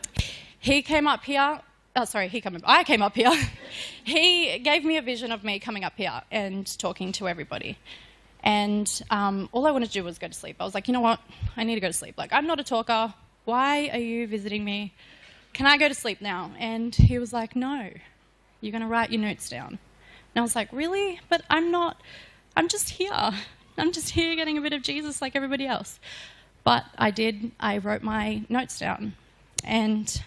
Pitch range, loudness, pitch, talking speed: 210-285 Hz, -25 LUFS, 230 Hz, 215 wpm